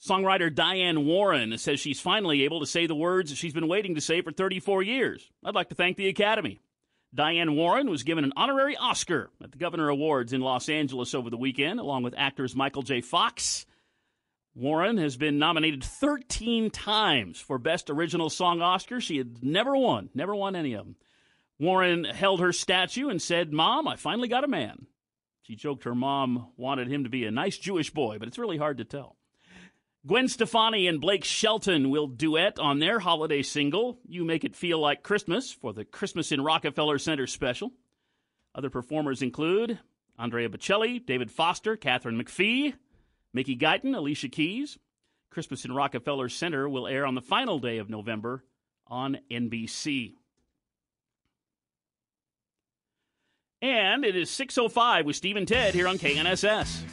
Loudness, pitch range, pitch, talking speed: -27 LUFS, 135-195 Hz, 160 Hz, 170 wpm